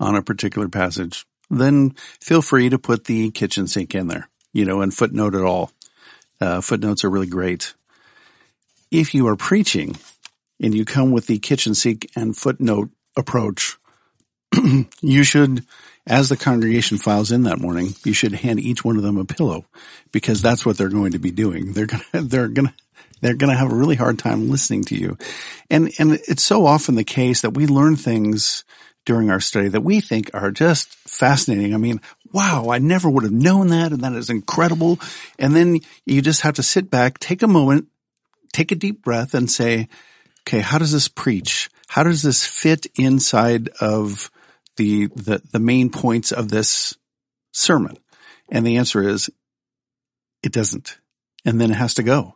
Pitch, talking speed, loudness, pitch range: 120 Hz, 185 wpm, -18 LUFS, 105-140 Hz